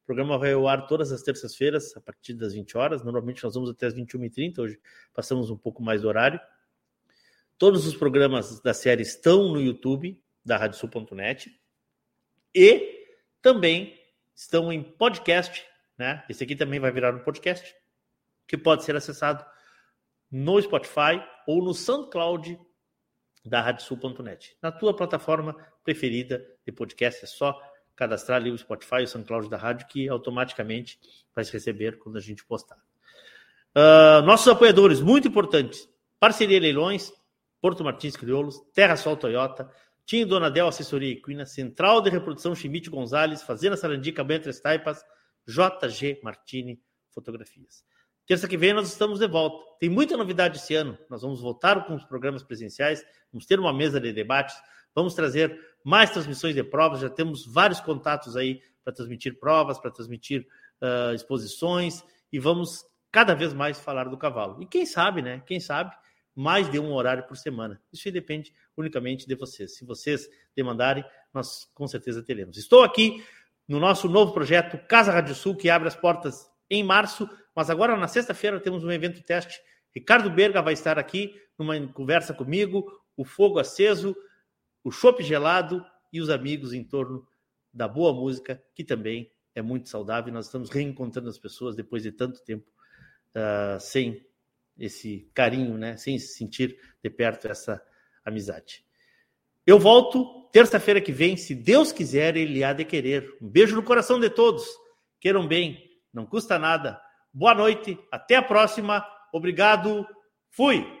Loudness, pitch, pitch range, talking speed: -23 LUFS, 150 Hz, 130-180 Hz, 160 wpm